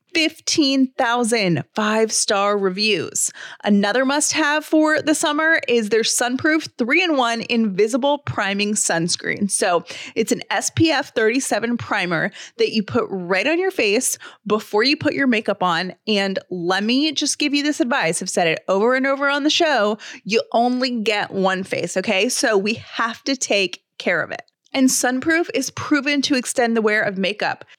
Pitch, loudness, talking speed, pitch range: 235 Hz, -19 LUFS, 170 wpm, 205-290 Hz